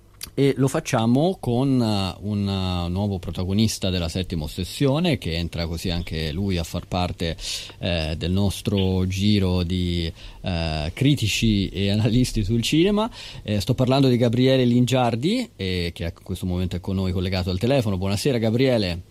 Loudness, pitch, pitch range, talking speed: -23 LUFS, 100 Hz, 90-125 Hz, 150 wpm